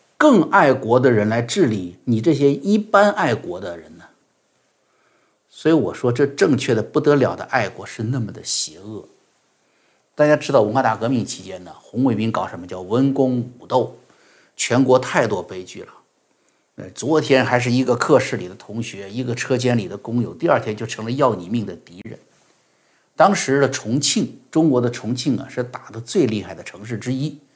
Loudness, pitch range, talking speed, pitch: -19 LUFS, 115-140 Hz, 270 characters per minute, 125 Hz